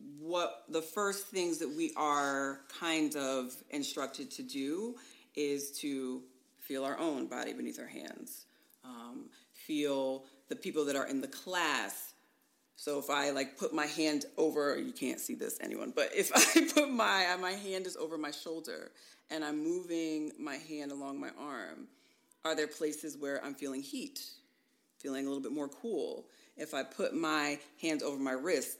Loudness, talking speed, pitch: -35 LUFS, 175 wpm, 155 Hz